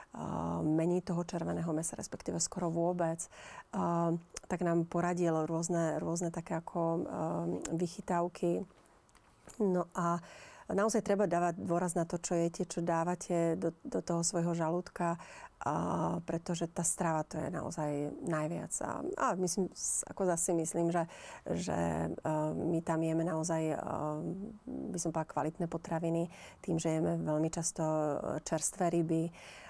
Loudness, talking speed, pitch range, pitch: -35 LUFS, 130 wpm, 160-175 Hz, 170 Hz